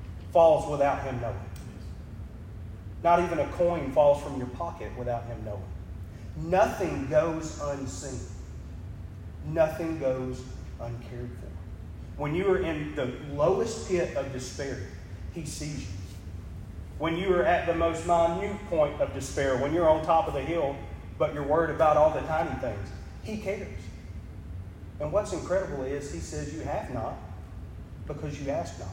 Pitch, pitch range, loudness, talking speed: 120 Hz, 90-150 Hz, -28 LUFS, 155 wpm